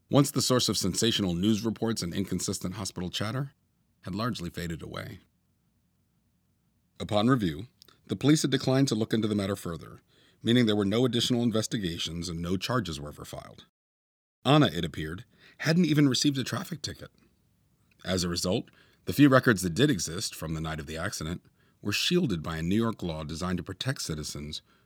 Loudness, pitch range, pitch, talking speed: -28 LUFS, 85-125 Hz, 105 Hz, 180 wpm